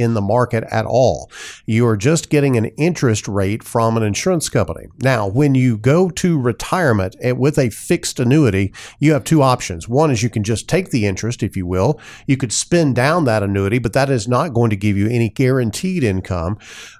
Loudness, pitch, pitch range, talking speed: -17 LUFS, 120 Hz, 110-140 Hz, 205 wpm